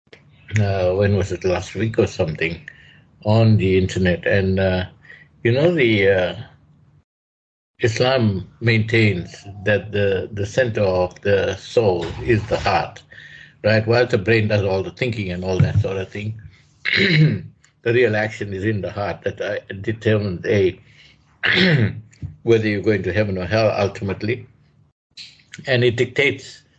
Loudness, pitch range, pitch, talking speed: -19 LUFS, 95-115 Hz, 105 Hz, 145 wpm